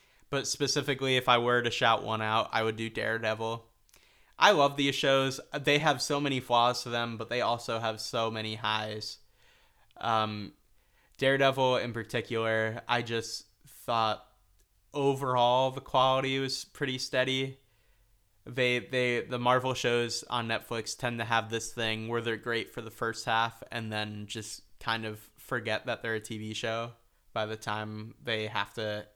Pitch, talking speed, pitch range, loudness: 115 Hz, 165 wpm, 110-130 Hz, -30 LUFS